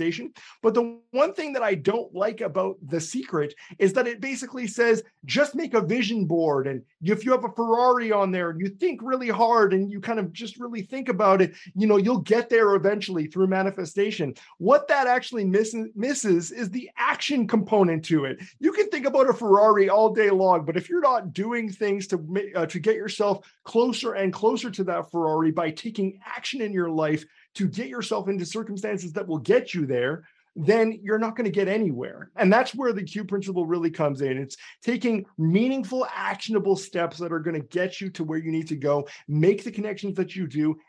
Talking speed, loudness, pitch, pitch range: 210 wpm, -24 LUFS, 200 Hz, 175-230 Hz